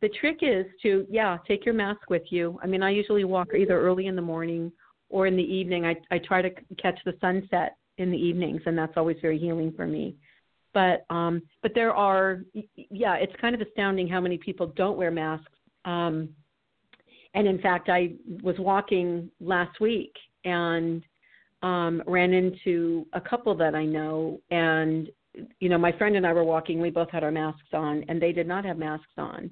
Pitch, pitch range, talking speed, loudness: 180 Hz, 165-190 Hz, 195 wpm, -27 LUFS